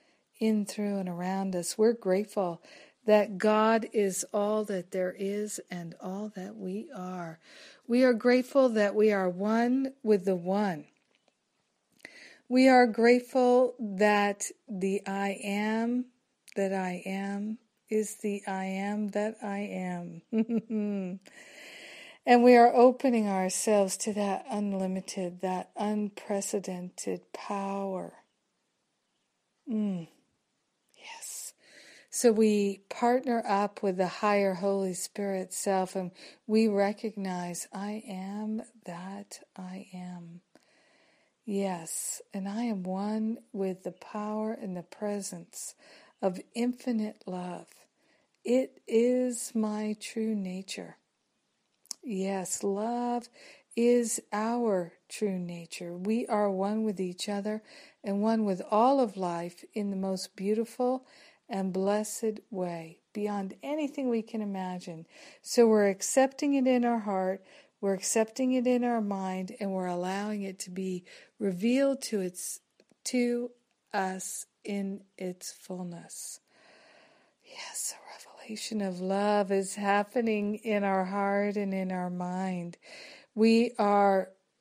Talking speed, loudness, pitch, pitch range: 120 wpm, -30 LUFS, 205 Hz, 190-230 Hz